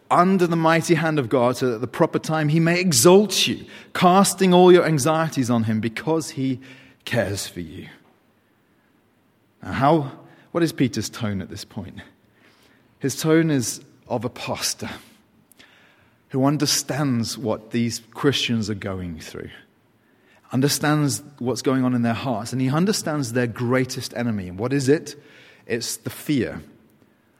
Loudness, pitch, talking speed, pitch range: -21 LUFS, 130 Hz, 155 wpm, 115-160 Hz